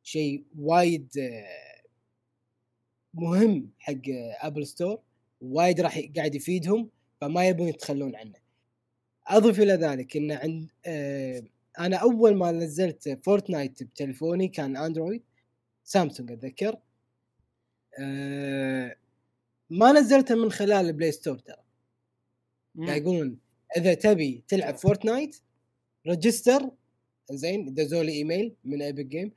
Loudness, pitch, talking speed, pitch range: -26 LUFS, 150 Hz, 100 wpm, 125-180 Hz